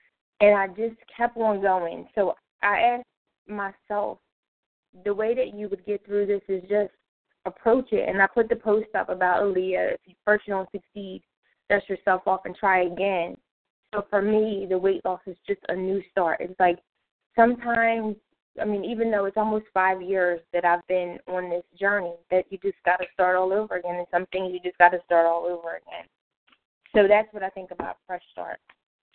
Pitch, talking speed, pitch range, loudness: 195 Hz, 200 wpm, 180-210 Hz, -25 LUFS